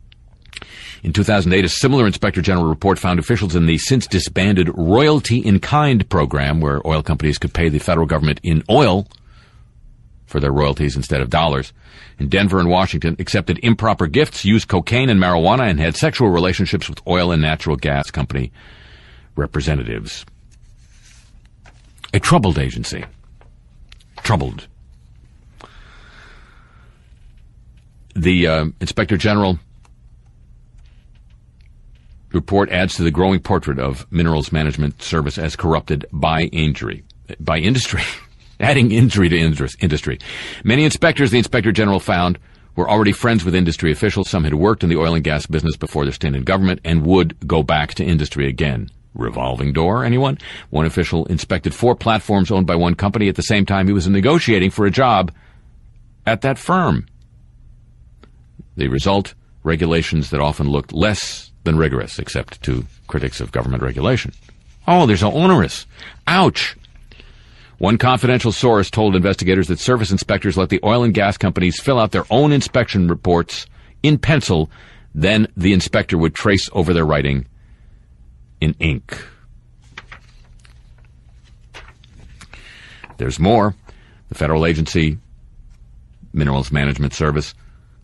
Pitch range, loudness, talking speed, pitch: 75-100 Hz, -17 LUFS, 135 wpm, 85 Hz